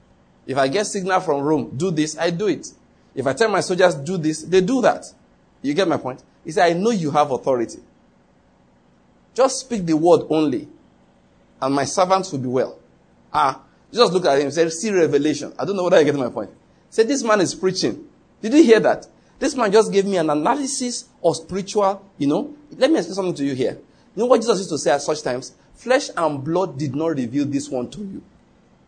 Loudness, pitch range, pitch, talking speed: -20 LUFS, 145-215 Hz, 170 Hz, 220 wpm